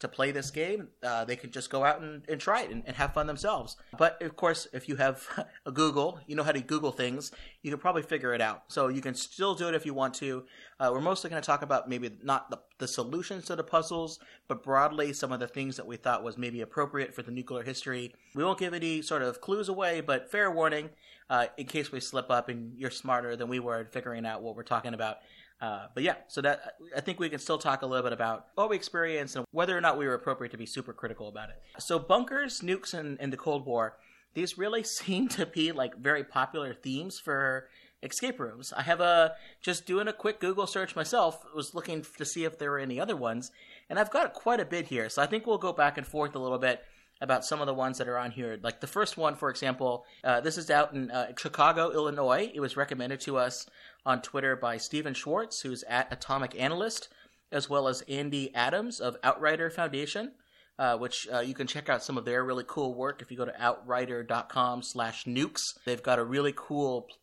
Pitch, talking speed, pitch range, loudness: 140 Hz, 240 wpm, 125-165 Hz, -31 LUFS